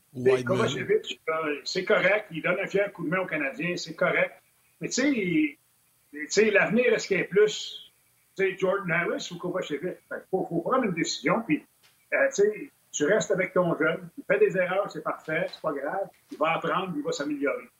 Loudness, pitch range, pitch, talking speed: -27 LUFS, 160-215 Hz, 190 Hz, 200 wpm